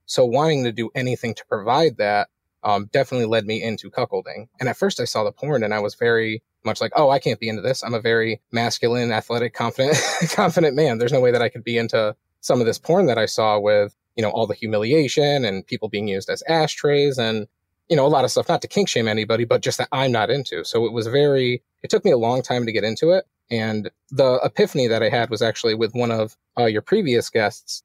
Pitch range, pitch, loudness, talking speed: 105-125 Hz, 115 Hz, -20 LUFS, 250 wpm